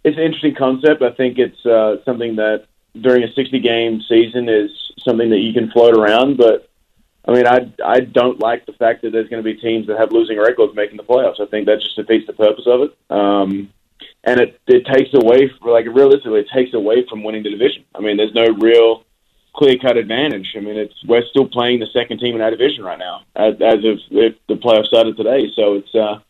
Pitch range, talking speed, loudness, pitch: 110-125 Hz, 230 wpm, -15 LUFS, 115 Hz